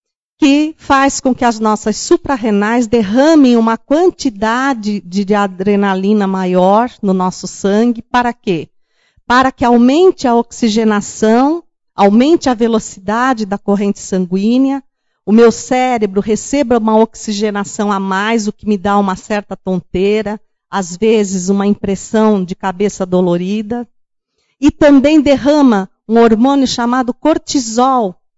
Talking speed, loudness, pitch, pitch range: 125 wpm, -13 LUFS, 220 Hz, 200-255 Hz